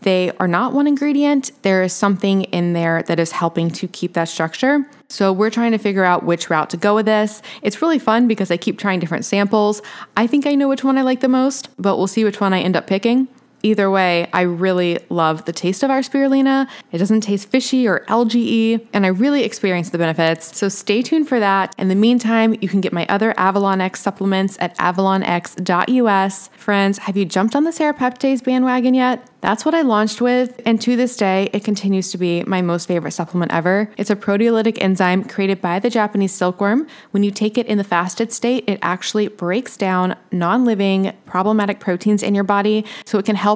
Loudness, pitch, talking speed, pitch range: -17 LUFS, 205 Hz, 215 wpm, 185-235 Hz